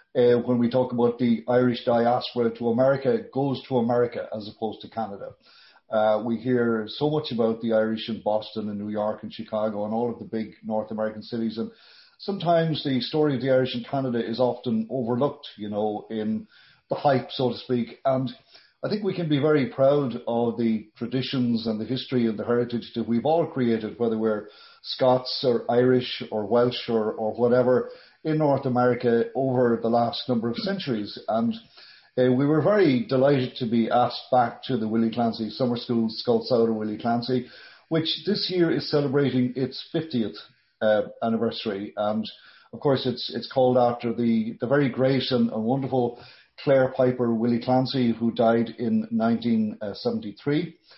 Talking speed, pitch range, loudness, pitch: 175 wpm, 115-135 Hz, -25 LUFS, 120 Hz